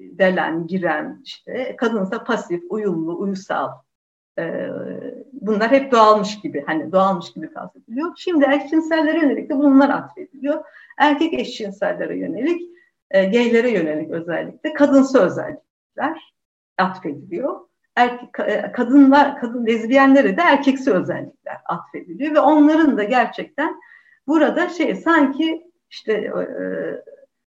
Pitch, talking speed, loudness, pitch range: 270 Hz, 110 wpm, -18 LUFS, 210-310 Hz